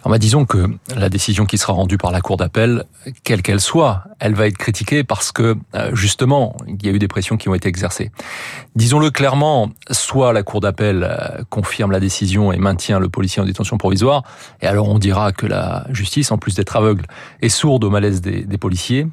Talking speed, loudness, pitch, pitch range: 210 wpm, -16 LUFS, 105 Hz, 100-120 Hz